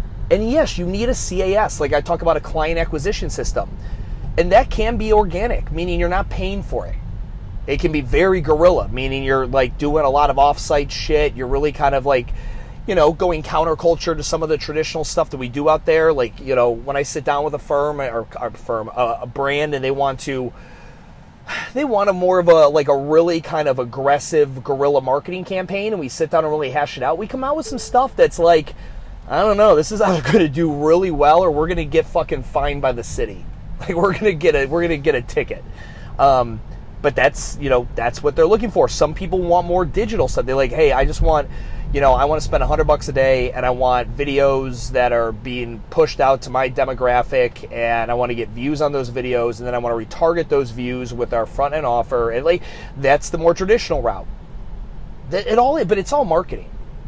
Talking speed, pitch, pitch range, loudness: 235 wpm, 145 Hz, 130-170 Hz, -18 LUFS